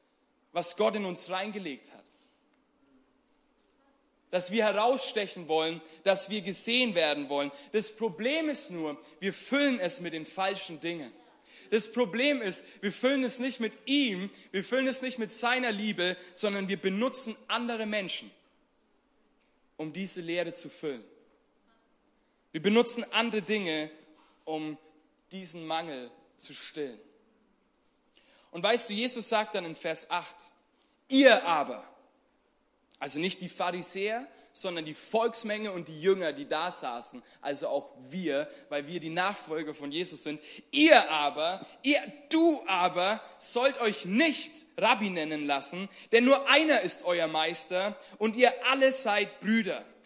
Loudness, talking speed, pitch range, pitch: -29 LUFS, 140 wpm, 175-260 Hz, 210 Hz